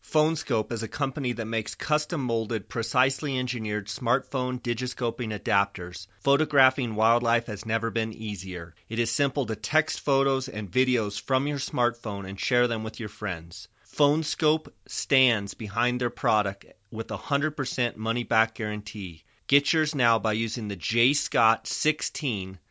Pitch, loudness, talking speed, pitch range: 115 Hz, -26 LUFS, 150 wpm, 110-135 Hz